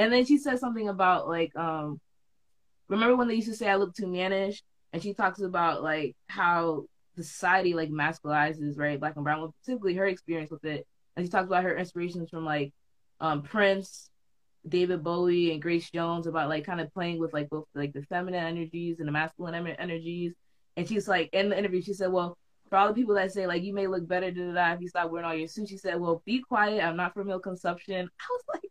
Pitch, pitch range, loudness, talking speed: 175 Hz, 165-195 Hz, -29 LUFS, 230 wpm